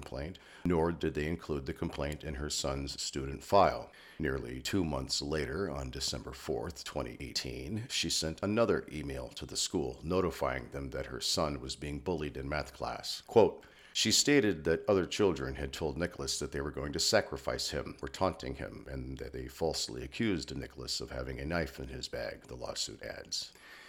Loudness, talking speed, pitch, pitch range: -34 LUFS, 185 wpm, 75 Hz, 70-85 Hz